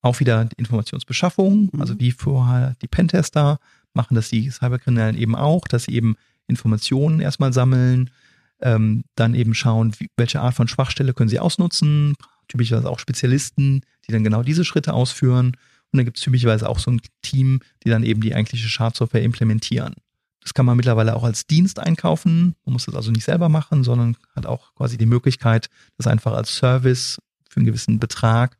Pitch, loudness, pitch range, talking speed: 125 Hz, -19 LUFS, 115-140 Hz, 185 wpm